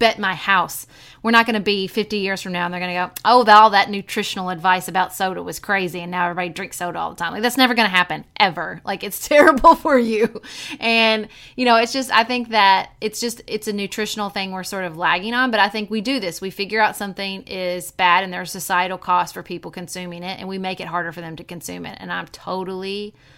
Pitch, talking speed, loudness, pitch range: 195 Hz, 250 wpm, -19 LUFS, 180-220 Hz